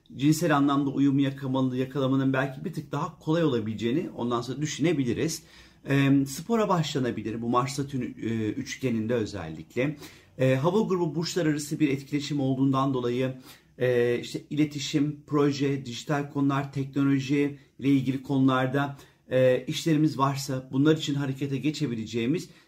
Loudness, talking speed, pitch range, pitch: -27 LUFS, 125 wpm, 130-150 Hz, 140 Hz